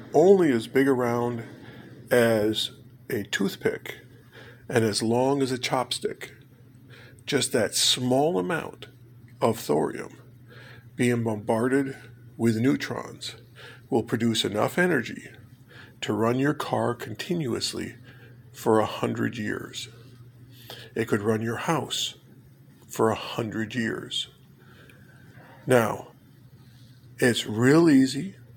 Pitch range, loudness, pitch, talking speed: 115-130 Hz, -25 LUFS, 125 Hz, 105 wpm